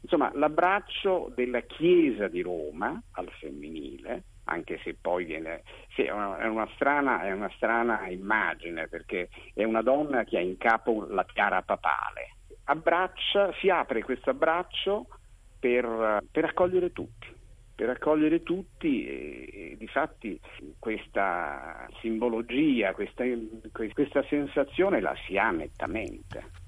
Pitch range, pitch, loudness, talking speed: 110-180 Hz, 125 Hz, -28 LUFS, 125 wpm